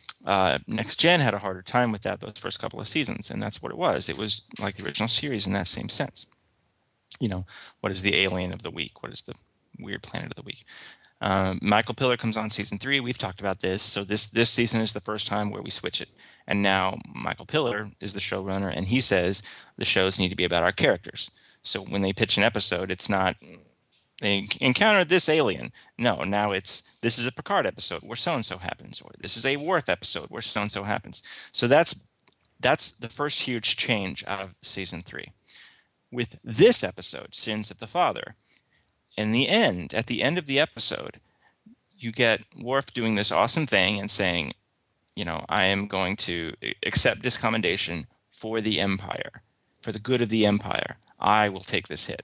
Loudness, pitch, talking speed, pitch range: -25 LUFS, 105 Hz, 210 wpm, 95-120 Hz